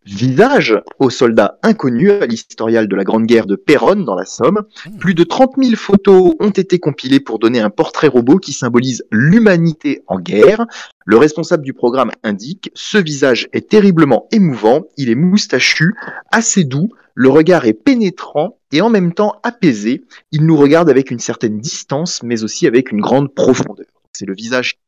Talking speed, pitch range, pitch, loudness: 175 wpm, 125-210 Hz, 165 Hz, -12 LUFS